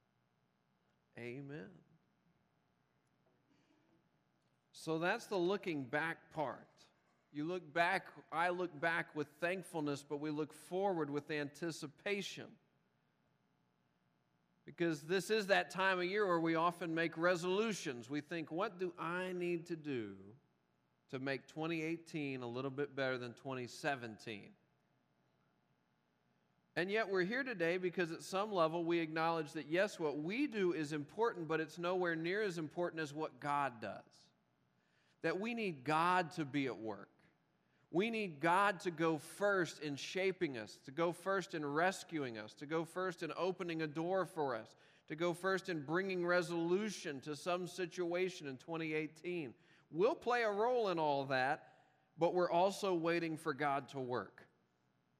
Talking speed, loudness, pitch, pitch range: 150 wpm, -39 LUFS, 165 Hz, 145-180 Hz